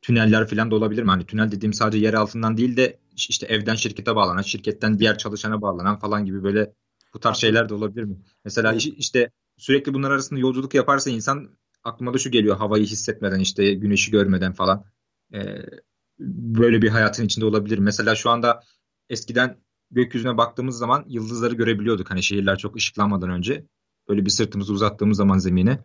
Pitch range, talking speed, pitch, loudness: 105-120 Hz, 170 wpm, 110 Hz, -21 LUFS